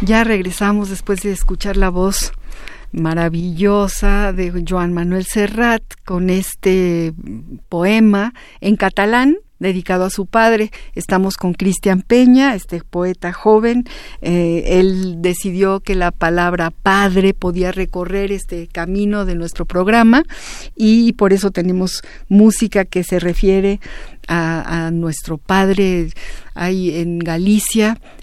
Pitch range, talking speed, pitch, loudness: 175-205 Hz, 120 wpm, 190 Hz, -16 LUFS